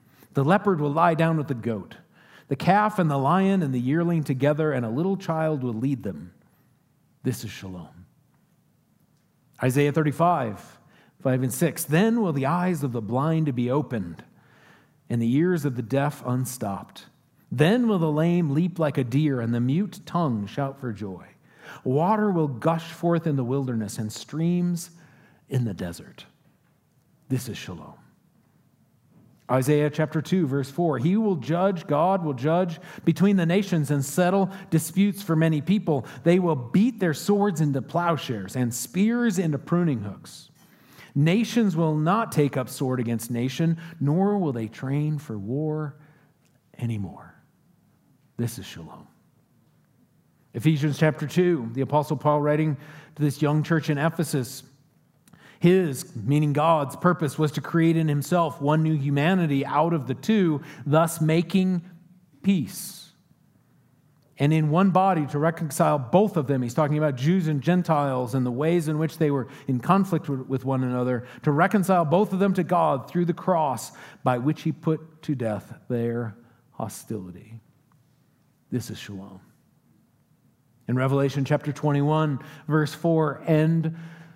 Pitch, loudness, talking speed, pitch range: 150 Hz, -24 LUFS, 155 wpm, 135-170 Hz